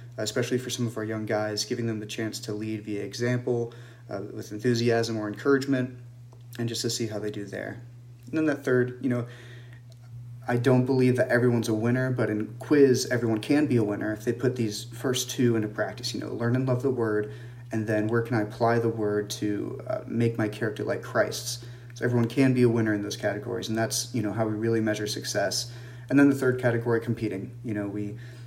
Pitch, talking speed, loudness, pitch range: 120 Hz, 225 wpm, -27 LUFS, 110-125 Hz